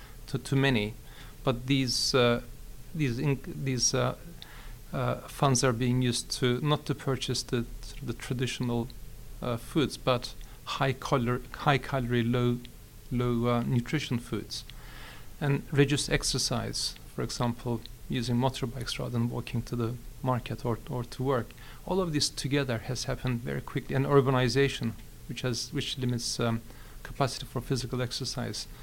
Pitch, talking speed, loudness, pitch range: 125 Hz, 145 wpm, -30 LUFS, 120-135 Hz